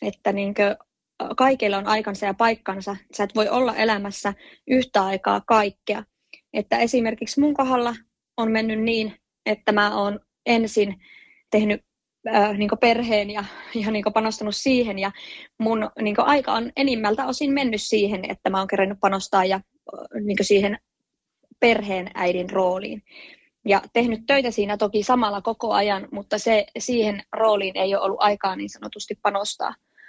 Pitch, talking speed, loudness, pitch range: 210 Hz, 150 wpm, -22 LUFS, 200-230 Hz